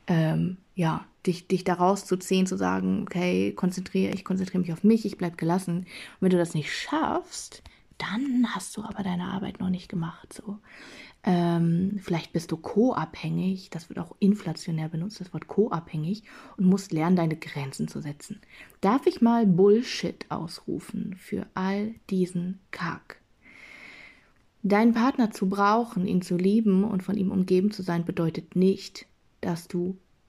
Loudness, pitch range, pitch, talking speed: -27 LUFS, 170-205 Hz, 185 Hz, 160 wpm